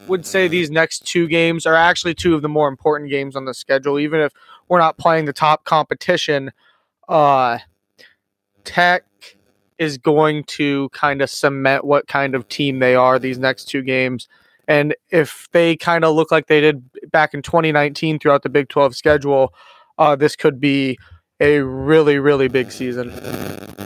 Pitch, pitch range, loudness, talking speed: 145 Hz, 135-160 Hz, -16 LUFS, 175 wpm